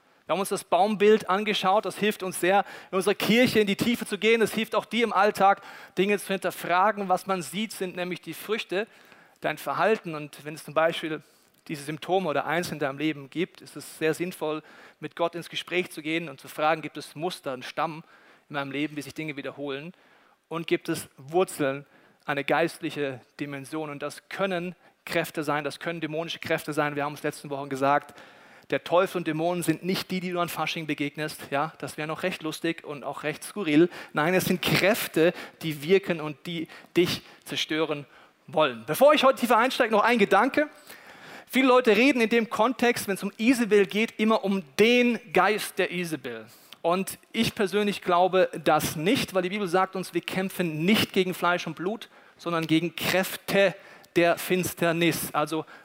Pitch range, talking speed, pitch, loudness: 155-195 Hz, 190 wpm, 175 Hz, -26 LUFS